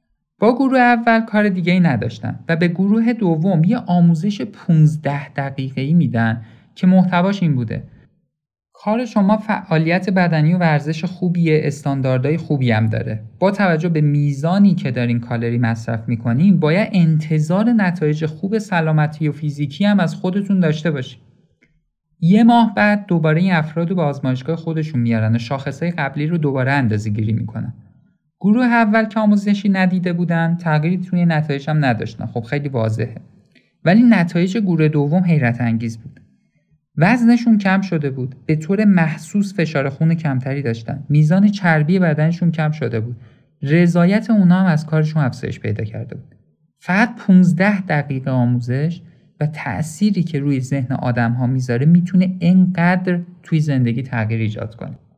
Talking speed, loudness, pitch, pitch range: 150 wpm, -17 LUFS, 160 Hz, 135-185 Hz